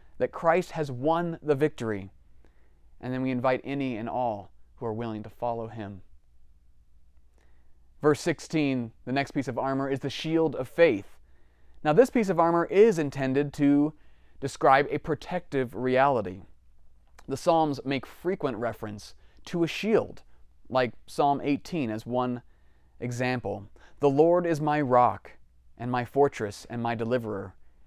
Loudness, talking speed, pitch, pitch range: -27 LUFS, 145 wpm, 125 Hz, 90-145 Hz